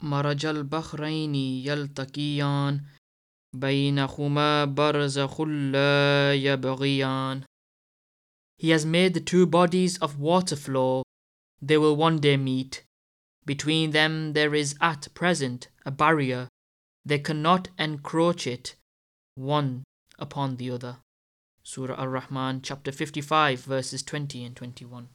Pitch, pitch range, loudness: 140 Hz, 130-155 Hz, -25 LUFS